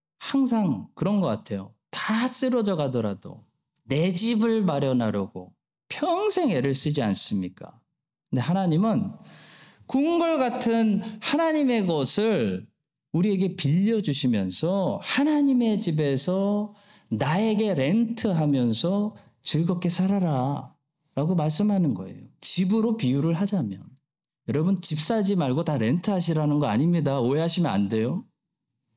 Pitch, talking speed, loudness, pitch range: 180 Hz, 265 characters per minute, -24 LUFS, 140-215 Hz